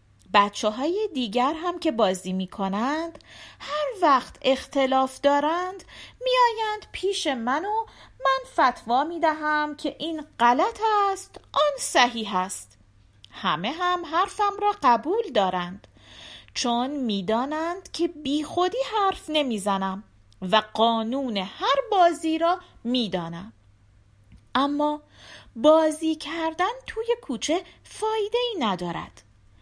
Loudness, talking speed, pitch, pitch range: -24 LUFS, 115 wpm, 285 Hz, 215-350 Hz